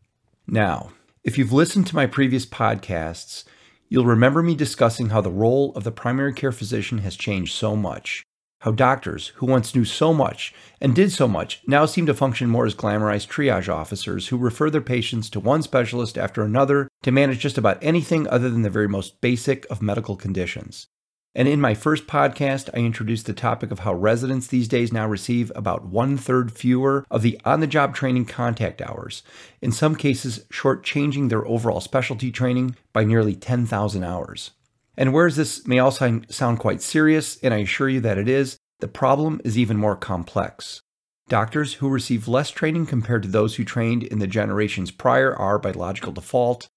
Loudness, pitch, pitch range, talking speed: -21 LUFS, 120 Hz, 105-135 Hz, 185 wpm